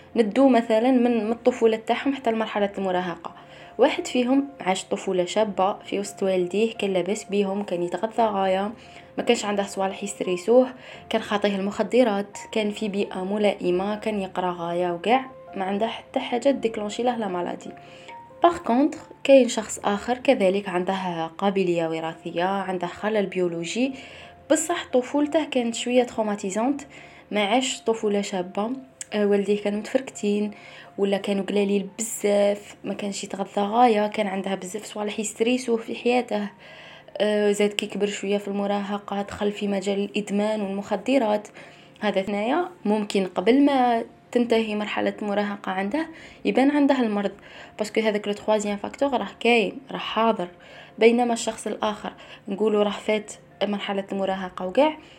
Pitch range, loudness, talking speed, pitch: 195-235 Hz, -24 LUFS, 135 wpm, 210 Hz